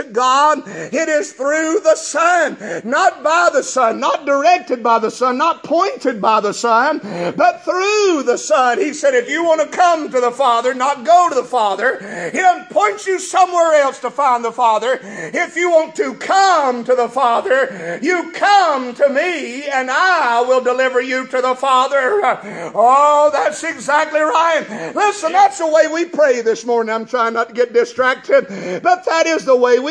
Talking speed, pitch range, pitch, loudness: 185 wpm, 255-350 Hz, 300 Hz, -15 LUFS